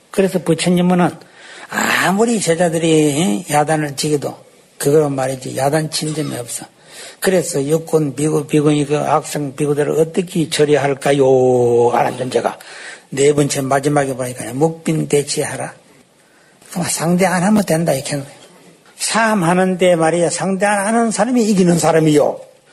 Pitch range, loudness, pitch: 145-180 Hz, -16 LUFS, 155 Hz